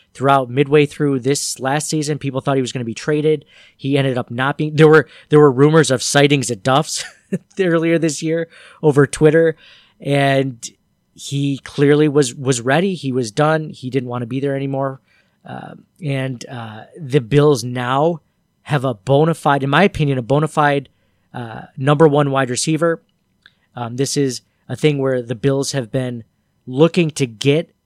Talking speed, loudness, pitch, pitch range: 180 wpm, -17 LUFS, 140 Hz, 130-155 Hz